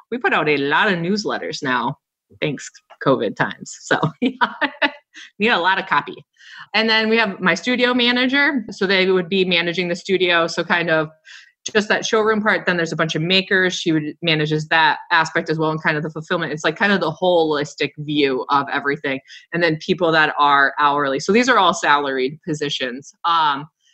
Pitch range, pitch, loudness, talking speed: 150-200 Hz, 170 Hz, -18 LUFS, 200 wpm